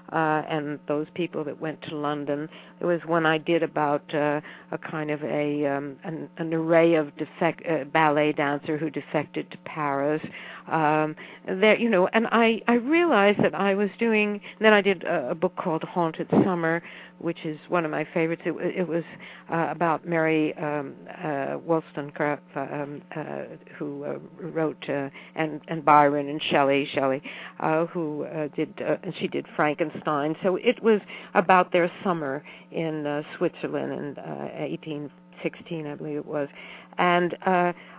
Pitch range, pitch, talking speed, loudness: 150-175 Hz, 160 Hz, 170 wpm, -25 LUFS